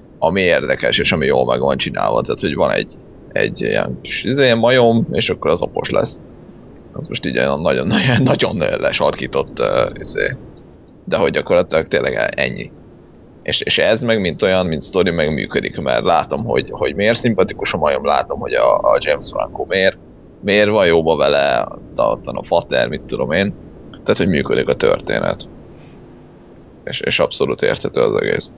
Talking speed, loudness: 170 wpm, -16 LUFS